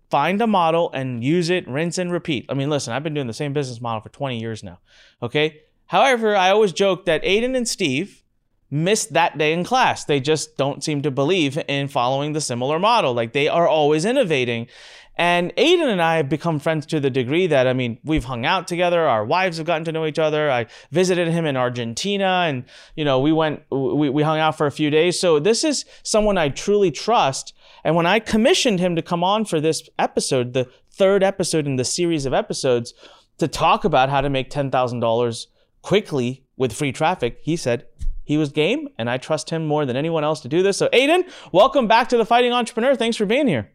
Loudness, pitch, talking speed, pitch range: -20 LUFS, 155 Hz, 220 wpm, 135-185 Hz